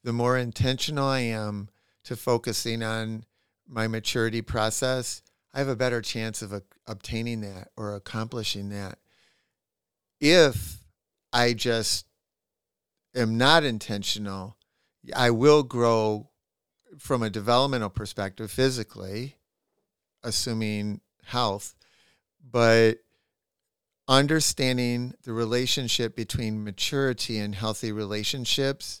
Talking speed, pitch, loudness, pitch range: 100 wpm, 115 Hz, -26 LUFS, 105-125 Hz